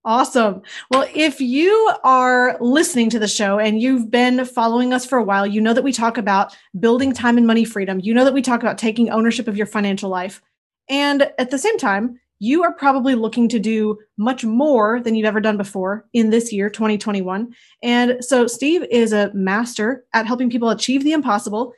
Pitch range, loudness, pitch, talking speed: 215-255 Hz, -17 LUFS, 235 Hz, 205 wpm